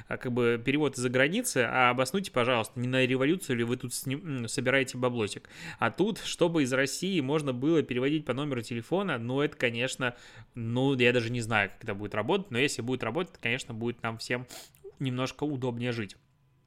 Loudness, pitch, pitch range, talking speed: -29 LUFS, 130 Hz, 120-140 Hz, 185 wpm